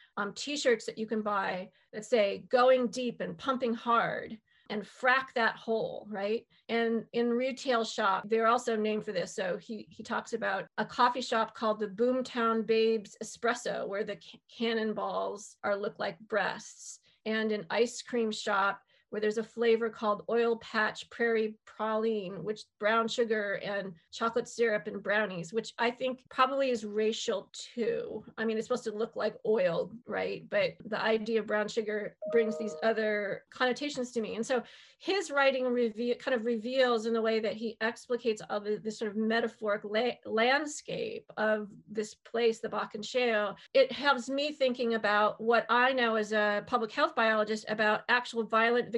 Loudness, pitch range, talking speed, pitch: -31 LUFS, 215-240 Hz, 175 wpm, 225 Hz